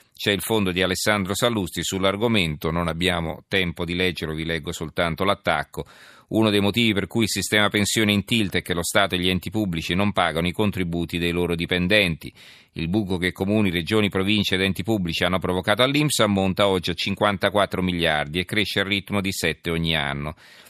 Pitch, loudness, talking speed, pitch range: 95 Hz, -22 LUFS, 190 wpm, 85-105 Hz